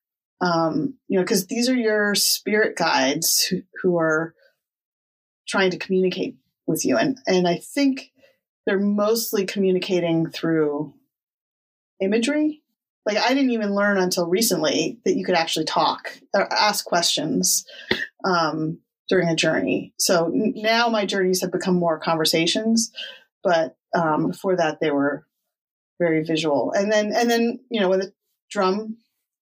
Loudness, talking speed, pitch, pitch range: -21 LUFS, 145 wpm, 195 Hz, 170-220 Hz